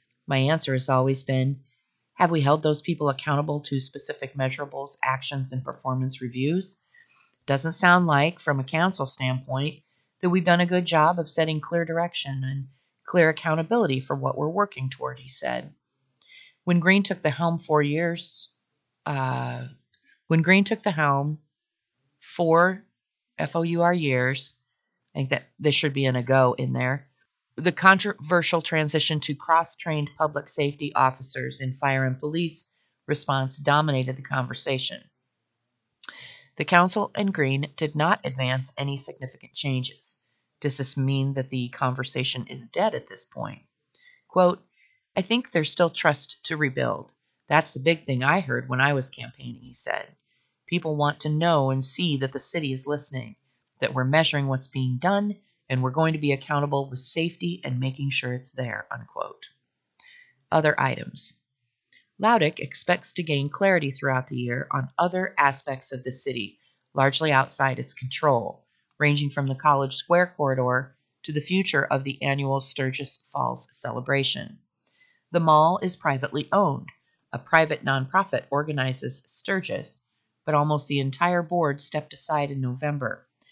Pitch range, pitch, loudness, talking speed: 130-165 Hz, 145 Hz, -25 LUFS, 155 wpm